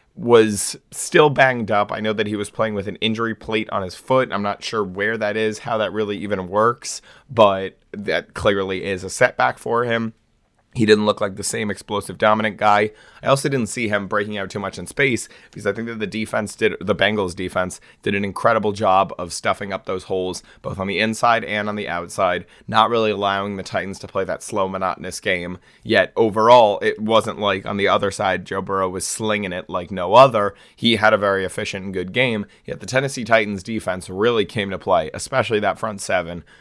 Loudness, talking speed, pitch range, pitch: -20 LUFS, 215 wpm, 95-110 Hz, 105 Hz